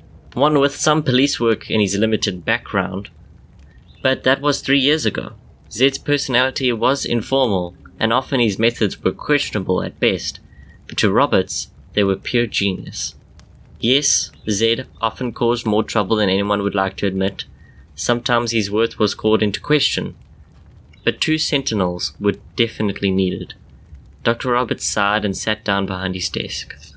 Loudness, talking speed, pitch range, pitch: -19 LUFS, 150 wpm, 95-120 Hz, 110 Hz